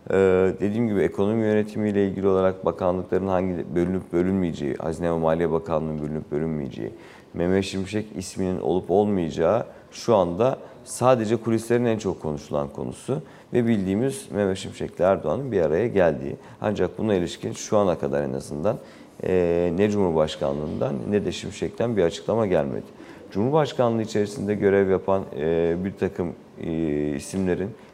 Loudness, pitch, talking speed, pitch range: -24 LUFS, 95 Hz, 135 wpm, 80-100 Hz